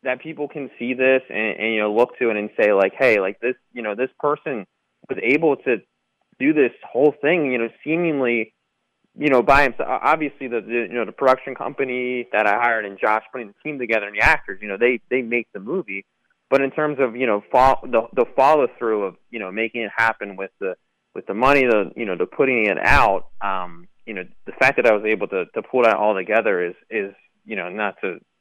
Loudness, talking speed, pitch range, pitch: -20 LUFS, 230 wpm, 110-135 Hz, 120 Hz